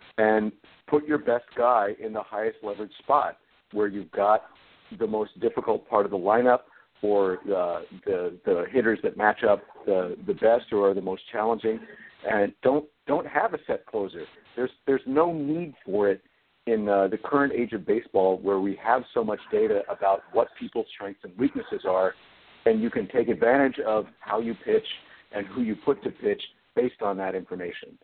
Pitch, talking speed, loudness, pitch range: 115 Hz, 190 wpm, -26 LUFS, 100-150 Hz